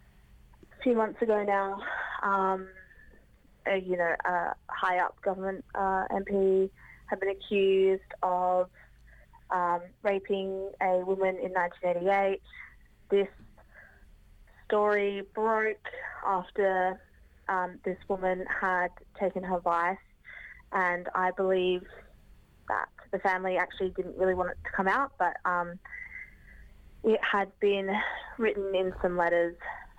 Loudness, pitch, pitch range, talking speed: -30 LUFS, 190 Hz, 180-200 Hz, 115 wpm